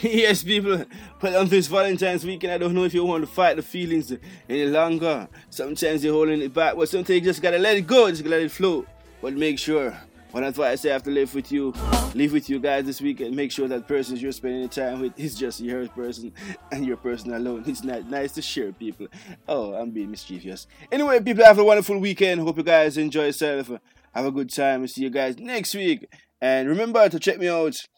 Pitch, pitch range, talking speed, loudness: 150 Hz, 130-185 Hz, 230 wpm, -22 LUFS